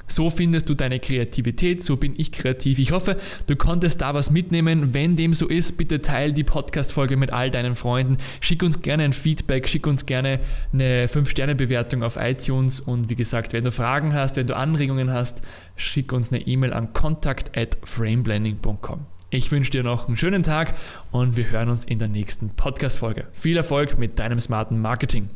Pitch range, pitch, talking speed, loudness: 120-150 Hz, 135 Hz, 190 wpm, -22 LUFS